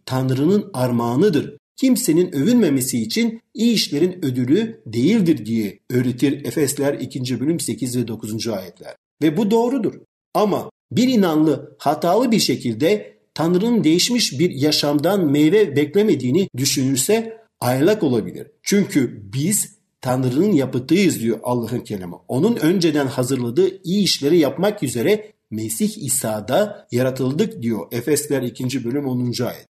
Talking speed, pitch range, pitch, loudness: 120 wpm, 125-200 Hz, 145 Hz, -19 LUFS